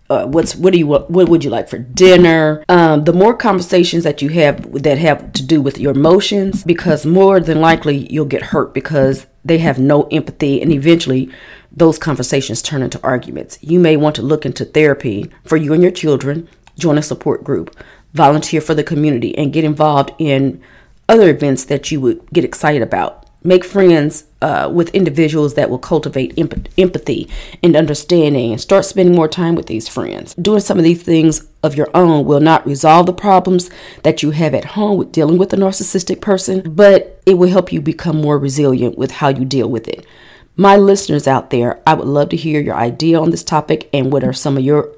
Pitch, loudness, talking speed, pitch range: 155 Hz, -13 LUFS, 205 wpm, 140-175 Hz